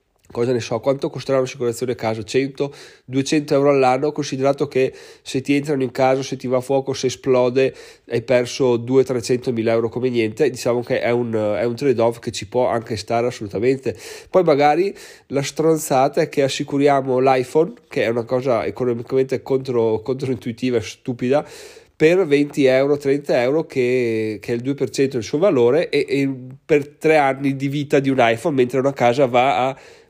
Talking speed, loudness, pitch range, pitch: 180 wpm, -19 LUFS, 125-140 Hz, 130 Hz